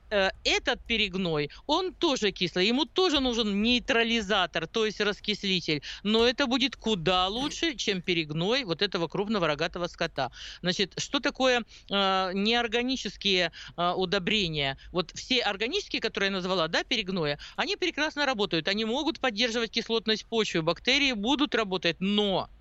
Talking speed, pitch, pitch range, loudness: 135 wpm, 210 Hz, 180-245 Hz, -27 LUFS